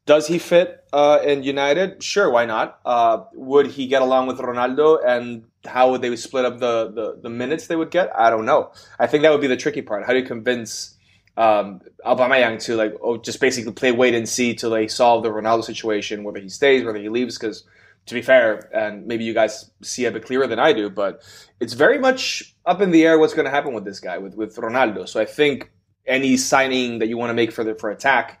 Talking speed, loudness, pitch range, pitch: 240 wpm, -19 LUFS, 115-140 Hz, 125 Hz